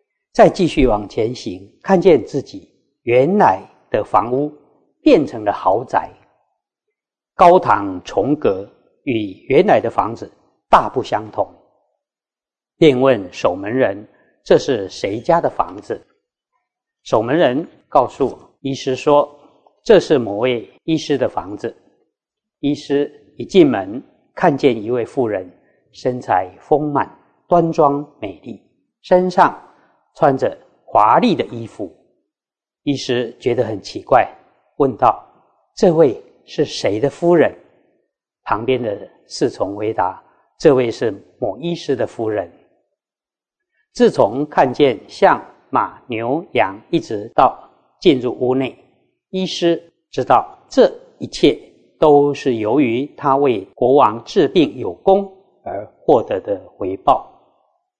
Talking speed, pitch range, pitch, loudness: 170 characters per minute, 135-195 Hz, 150 Hz, -17 LUFS